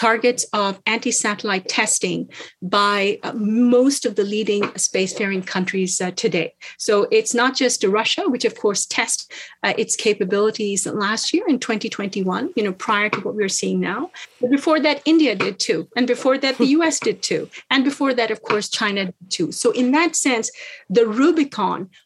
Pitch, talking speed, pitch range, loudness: 225 Hz, 175 wpm, 205-265 Hz, -19 LUFS